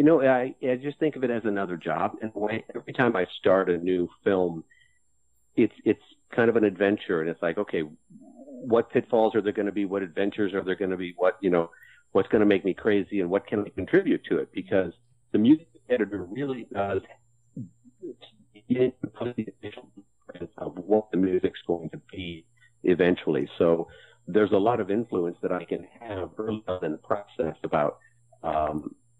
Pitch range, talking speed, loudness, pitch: 95-125 Hz, 190 wpm, -26 LUFS, 110 Hz